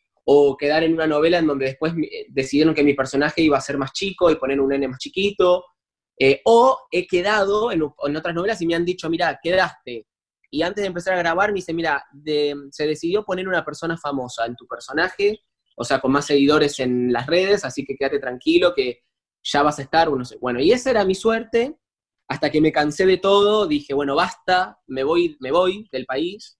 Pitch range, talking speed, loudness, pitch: 140-185 Hz, 215 wpm, -20 LUFS, 155 Hz